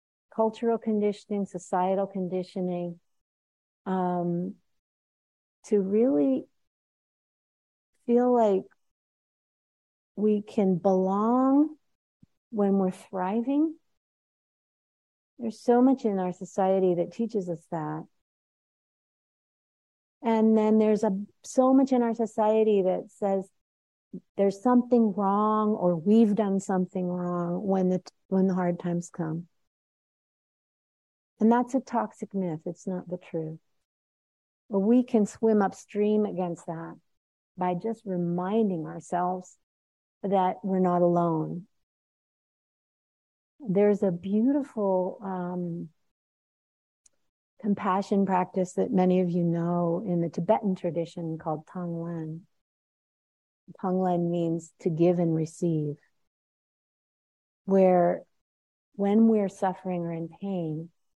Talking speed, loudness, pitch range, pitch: 105 wpm, -27 LUFS, 175-215 Hz, 190 Hz